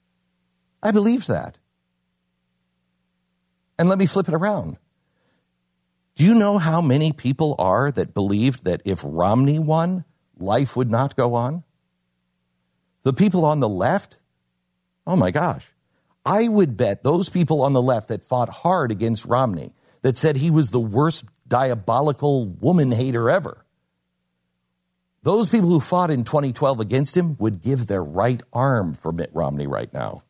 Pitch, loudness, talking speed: 120 Hz, -20 LUFS, 150 wpm